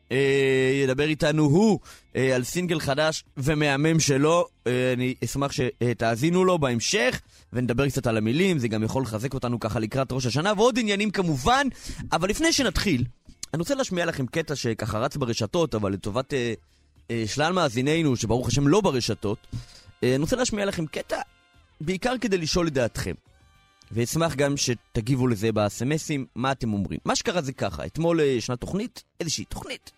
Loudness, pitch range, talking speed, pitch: -25 LUFS, 115-160 Hz, 150 wpm, 135 Hz